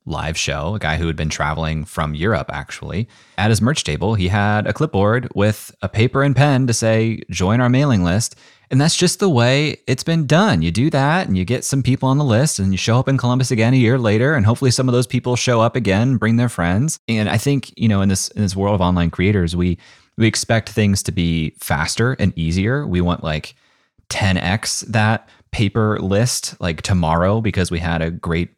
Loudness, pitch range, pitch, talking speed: -18 LUFS, 90-125 Hz, 110 Hz, 225 wpm